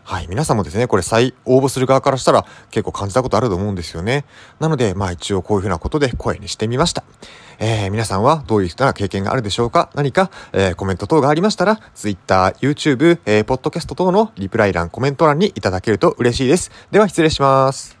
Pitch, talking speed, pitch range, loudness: 120 Hz, 515 characters per minute, 100-145 Hz, -17 LUFS